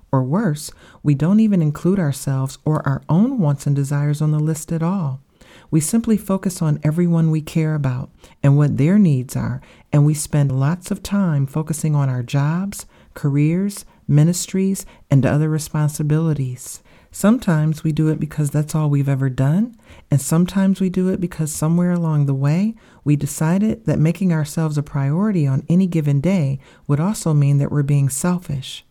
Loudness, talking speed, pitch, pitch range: -19 LUFS, 175 wpm, 155 Hz, 145-175 Hz